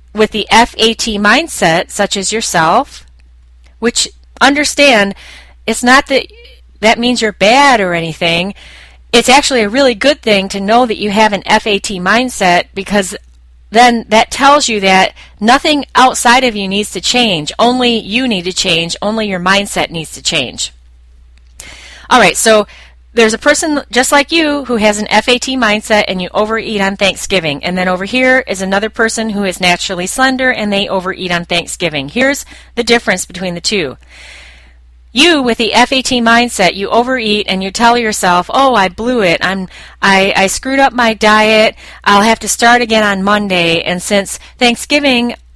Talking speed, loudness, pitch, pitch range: 170 wpm, -10 LUFS, 210 Hz, 185-240 Hz